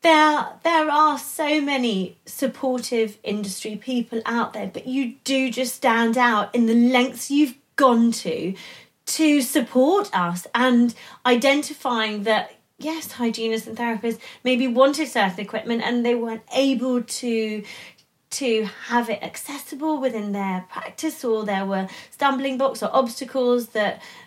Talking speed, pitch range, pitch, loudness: 140 wpm, 220-270 Hz, 245 Hz, -22 LUFS